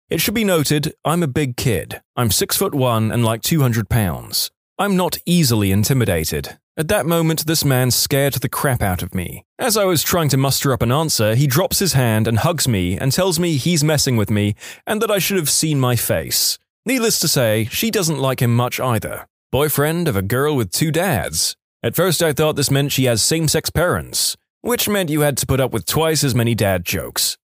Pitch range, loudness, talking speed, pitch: 115-165 Hz, -17 LUFS, 220 wpm, 140 Hz